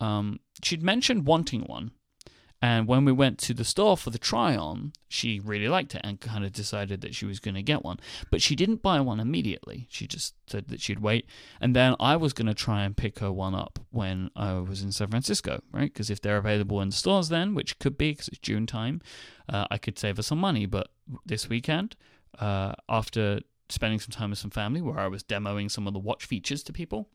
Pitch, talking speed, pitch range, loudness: 110 Hz, 235 wpm, 105-140 Hz, -28 LUFS